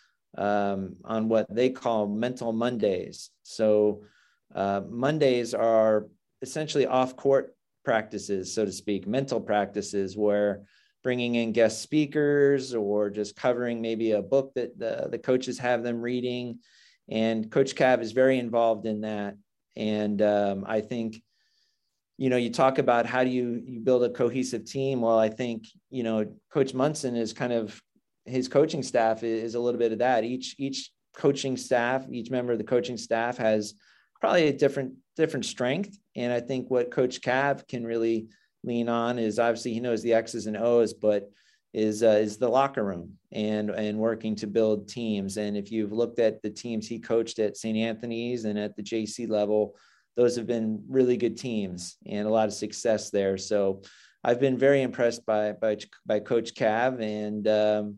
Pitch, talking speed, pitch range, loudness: 115 Hz, 175 wpm, 105-125 Hz, -27 LUFS